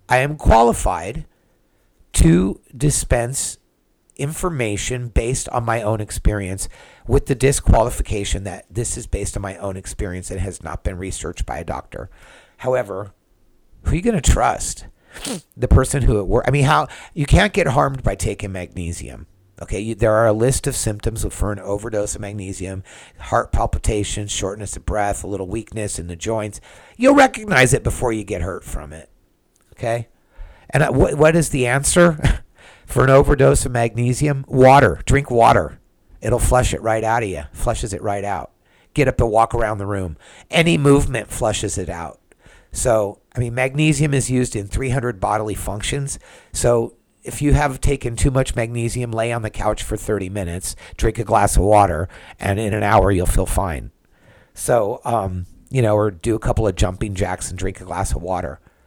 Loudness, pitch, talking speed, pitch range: -19 LUFS, 110 Hz, 180 wpm, 95-125 Hz